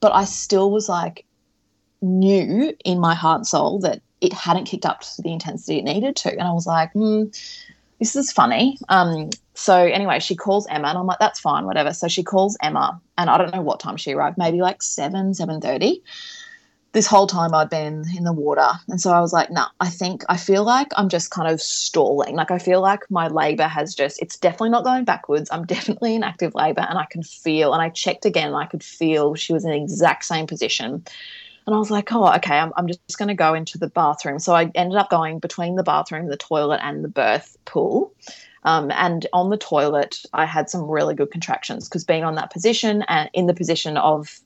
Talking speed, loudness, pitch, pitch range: 230 wpm, -20 LUFS, 180 Hz, 160-205 Hz